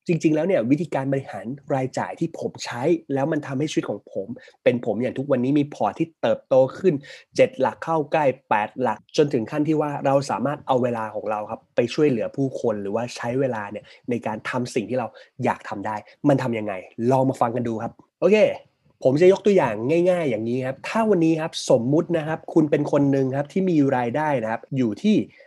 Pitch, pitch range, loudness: 140 Hz, 125-165 Hz, -23 LUFS